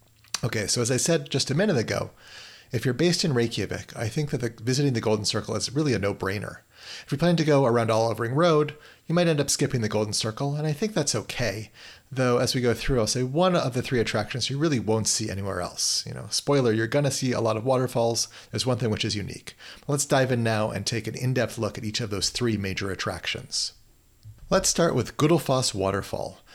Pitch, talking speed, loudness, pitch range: 120 Hz, 235 wpm, -25 LUFS, 110-140 Hz